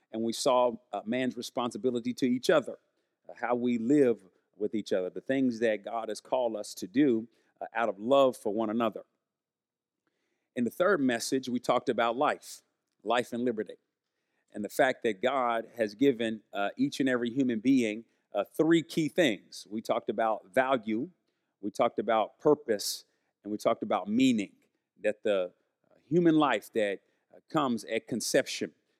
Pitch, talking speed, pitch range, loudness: 125 Hz, 170 wpm, 115-140 Hz, -30 LUFS